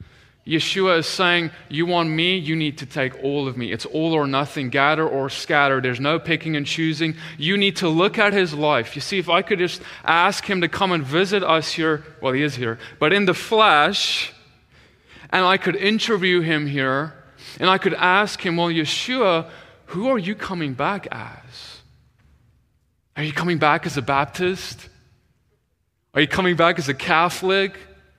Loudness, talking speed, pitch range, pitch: -20 LUFS, 185 wpm, 145-185 Hz, 160 Hz